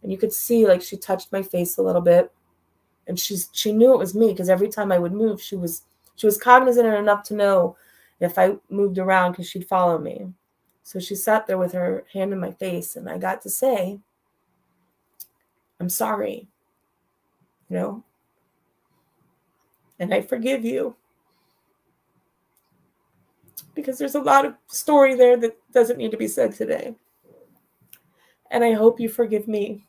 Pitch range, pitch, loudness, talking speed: 185-235 Hz, 205 Hz, -21 LUFS, 170 wpm